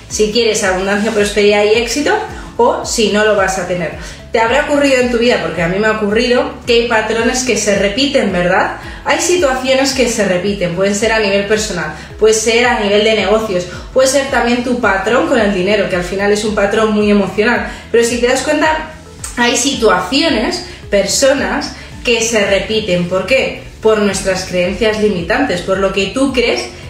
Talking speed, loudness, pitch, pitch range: 190 wpm, -13 LUFS, 220 Hz, 200-250 Hz